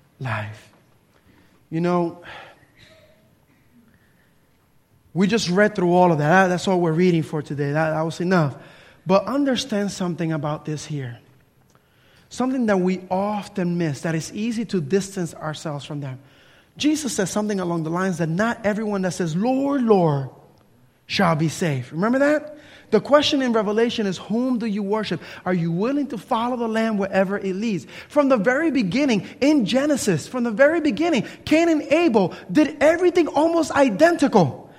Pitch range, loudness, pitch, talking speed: 165-250 Hz, -21 LUFS, 195 Hz, 160 wpm